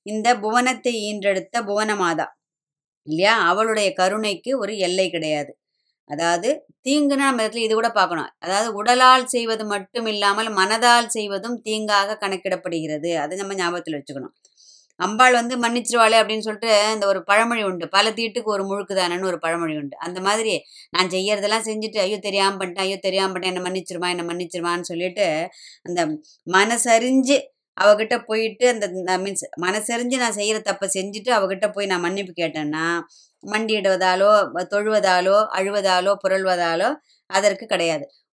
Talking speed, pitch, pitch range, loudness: 130 wpm, 200 Hz, 185-225 Hz, -20 LUFS